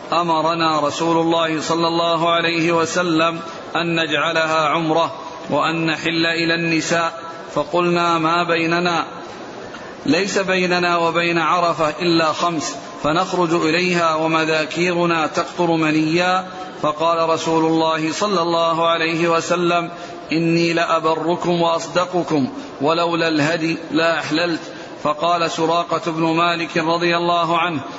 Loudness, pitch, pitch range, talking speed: -18 LUFS, 165 Hz, 160-170 Hz, 105 wpm